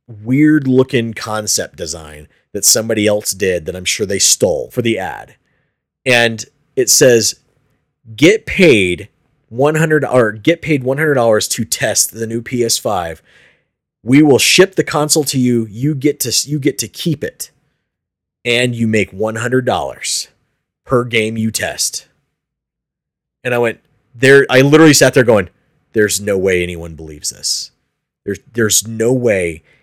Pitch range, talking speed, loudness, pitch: 110-145 Hz, 145 wpm, -13 LUFS, 120 Hz